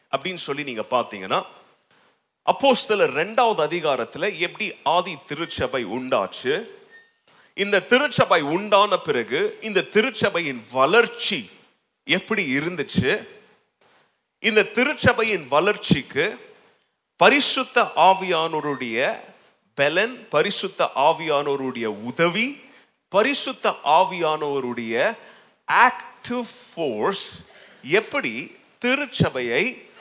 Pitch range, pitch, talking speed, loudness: 150-245 Hz, 205 Hz, 70 wpm, -21 LUFS